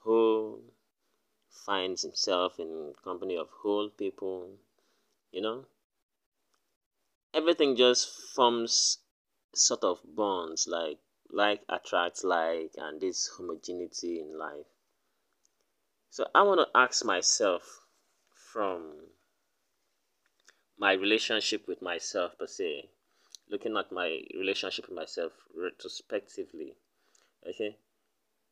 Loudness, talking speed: -30 LUFS, 95 wpm